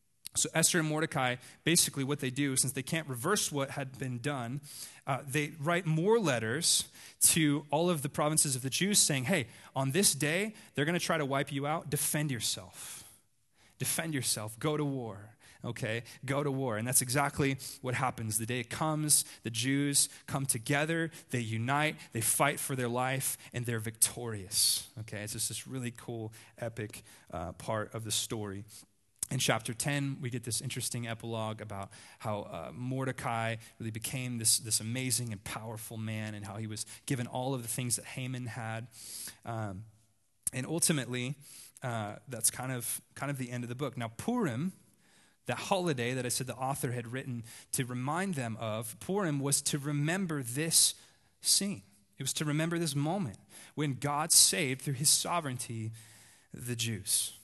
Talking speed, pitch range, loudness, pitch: 175 wpm, 115-150 Hz, -32 LUFS, 130 Hz